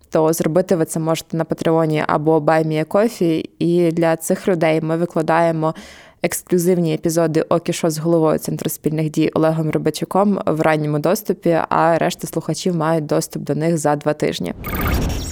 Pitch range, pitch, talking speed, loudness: 155-170 Hz, 165 Hz, 155 wpm, -18 LUFS